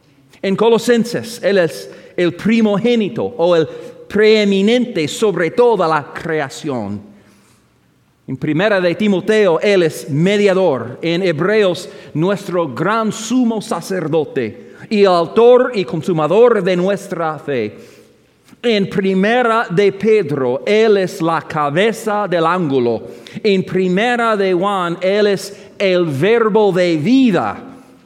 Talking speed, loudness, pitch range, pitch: 115 wpm, -15 LUFS, 165-215 Hz, 190 Hz